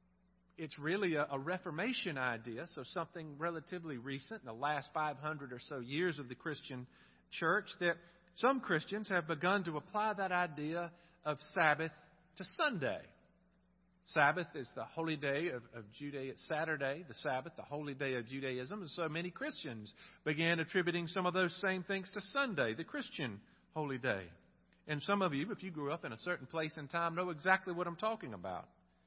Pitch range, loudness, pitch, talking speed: 140-180 Hz, -38 LUFS, 165 Hz, 180 wpm